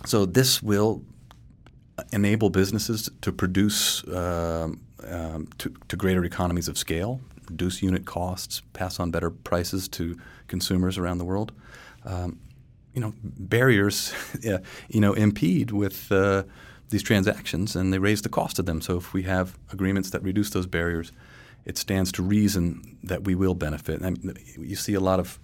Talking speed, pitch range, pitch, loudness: 165 wpm, 90-105 Hz, 95 Hz, -26 LUFS